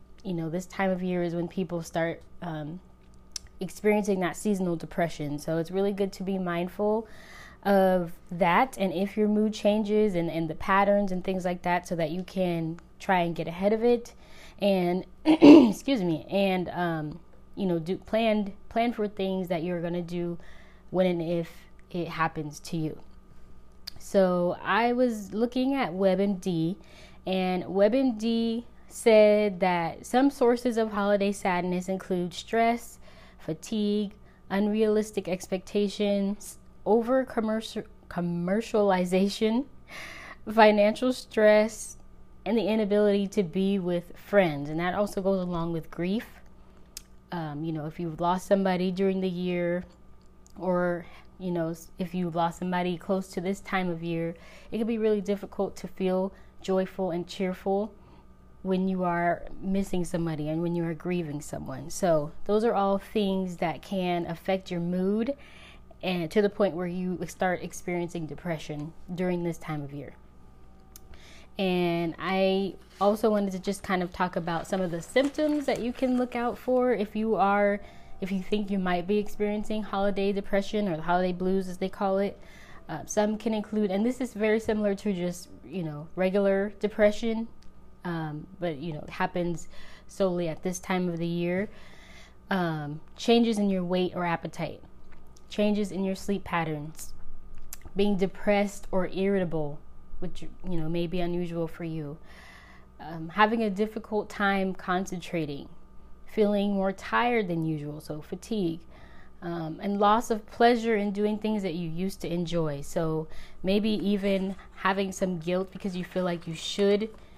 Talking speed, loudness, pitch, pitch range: 160 wpm, -28 LUFS, 185 Hz, 170-205 Hz